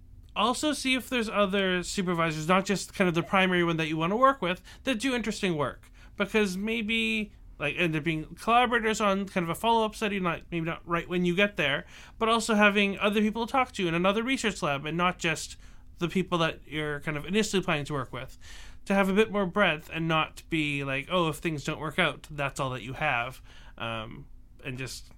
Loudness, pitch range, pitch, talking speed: -28 LUFS, 155-210 Hz, 180 Hz, 225 wpm